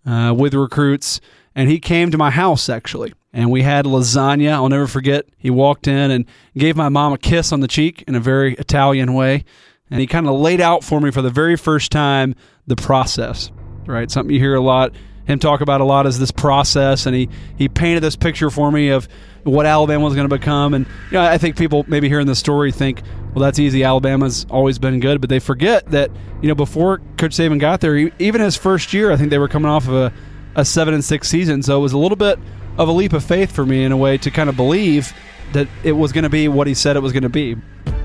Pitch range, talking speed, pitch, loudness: 130-150 Hz, 250 wpm, 140 Hz, -15 LUFS